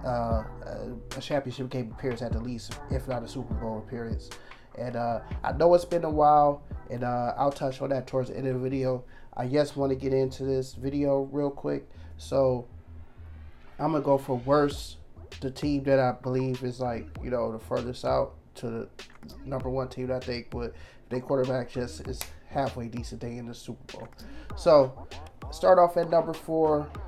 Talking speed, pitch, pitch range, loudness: 195 wpm, 130 Hz, 120-140 Hz, -28 LUFS